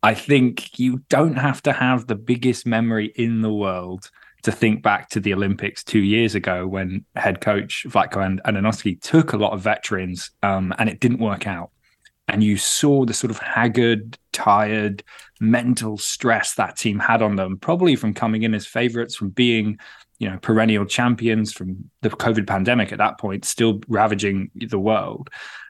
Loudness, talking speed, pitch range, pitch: -20 LUFS, 175 wpm, 100-120 Hz, 110 Hz